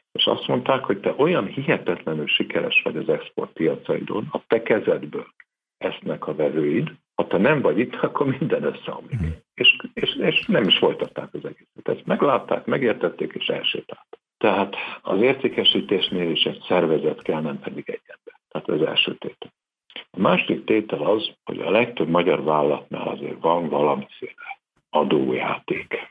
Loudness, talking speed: -22 LUFS, 150 wpm